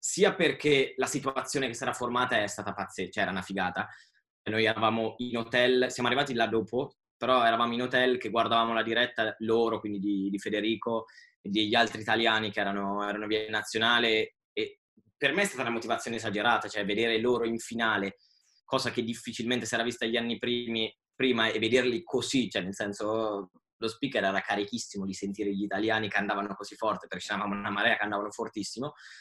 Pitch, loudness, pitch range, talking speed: 115 Hz, -29 LUFS, 105-120 Hz, 190 wpm